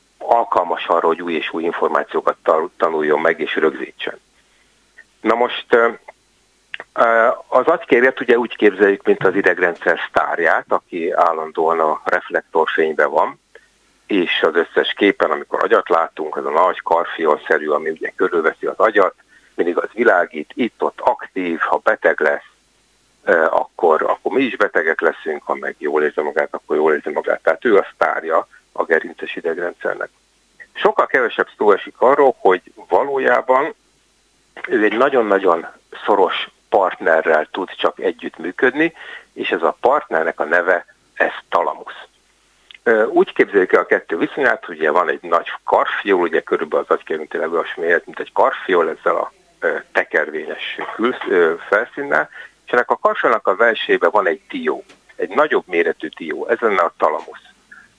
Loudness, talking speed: -17 LUFS, 145 wpm